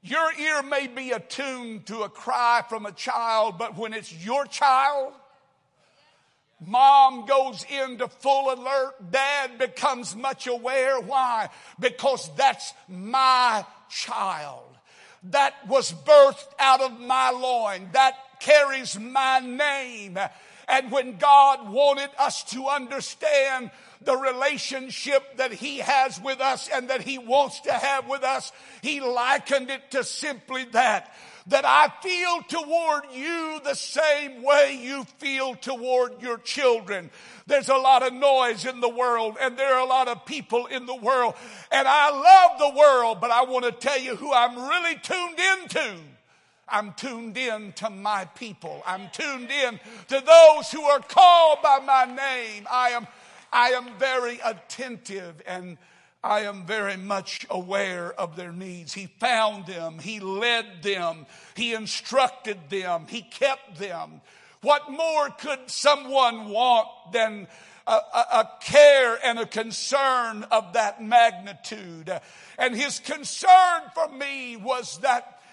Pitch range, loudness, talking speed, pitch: 225-275 Hz, -22 LUFS, 145 wpm, 260 Hz